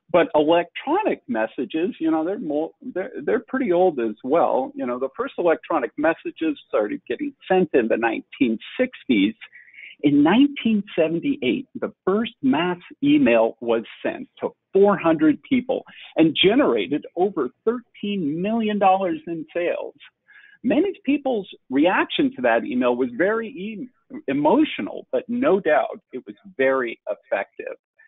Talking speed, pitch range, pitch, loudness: 130 wpm, 180-295 Hz, 250 Hz, -22 LUFS